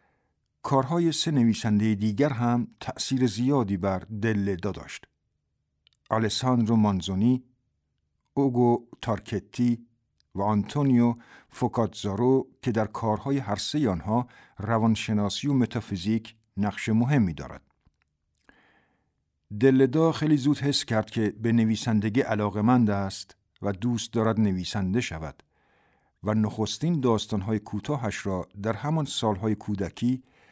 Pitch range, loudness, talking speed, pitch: 100-125 Hz, -26 LUFS, 105 wpm, 110 Hz